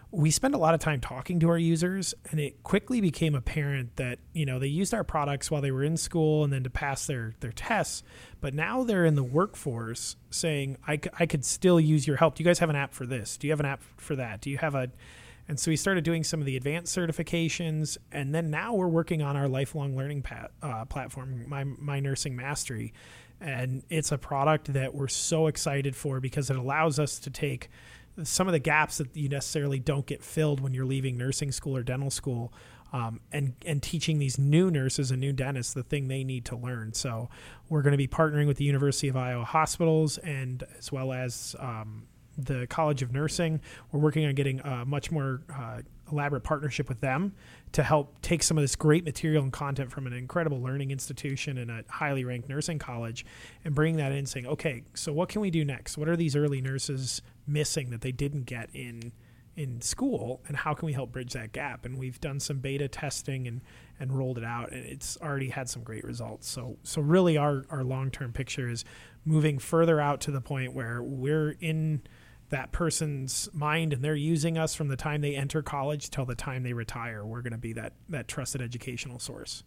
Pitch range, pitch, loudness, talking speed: 130-155 Hz, 140 Hz, -30 LUFS, 220 wpm